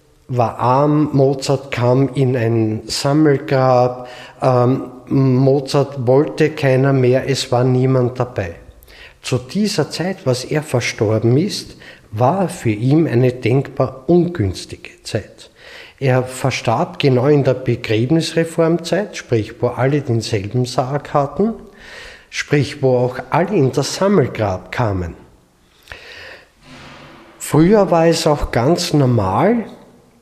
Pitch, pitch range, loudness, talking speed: 130 Hz, 125-150 Hz, -16 LUFS, 110 wpm